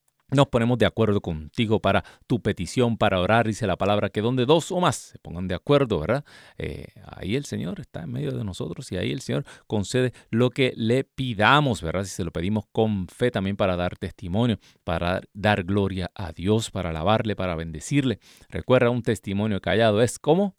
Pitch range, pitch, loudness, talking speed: 95-125 Hz, 105 Hz, -24 LUFS, 195 wpm